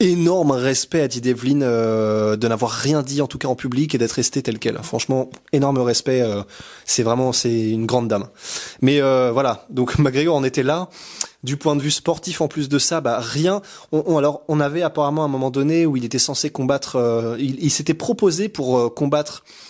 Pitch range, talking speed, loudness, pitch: 125-150 Hz, 220 wpm, -19 LUFS, 140 Hz